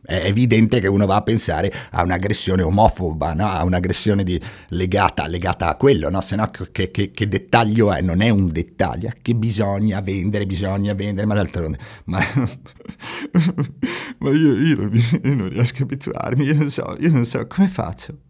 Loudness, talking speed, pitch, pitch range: -19 LUFS, 175 wpm, 105 Hz, 95-120 Hz